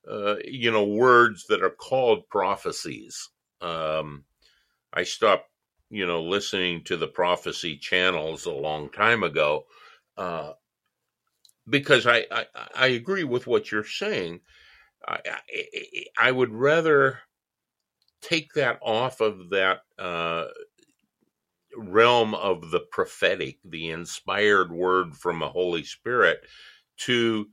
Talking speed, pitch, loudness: 120 wpm, 120 Hz, -24 LUFS